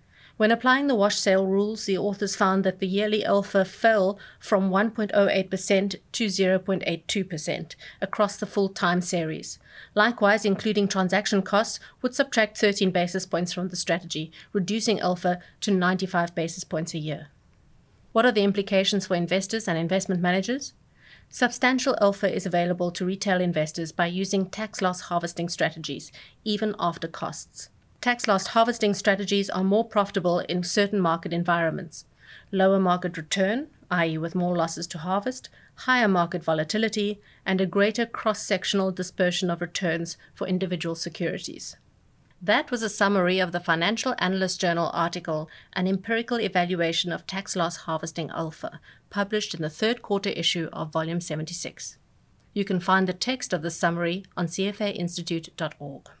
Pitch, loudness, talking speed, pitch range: 190 Hz, -25 LUFS, 145 wpm, 170-205 Hz